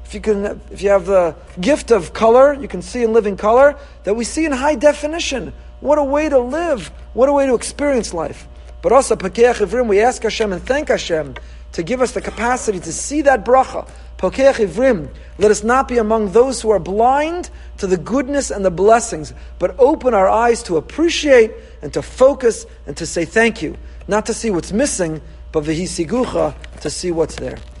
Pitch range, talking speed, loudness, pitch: 190-270 Hz, 190 wpm, -16 LUFS, 225 Hz